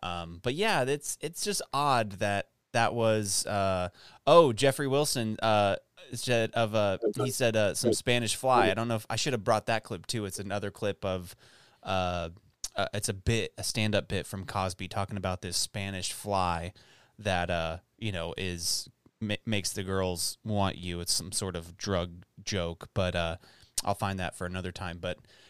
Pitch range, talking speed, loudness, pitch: 90-115 Hz, 190 wpm, -30 LUFS, 100 Hz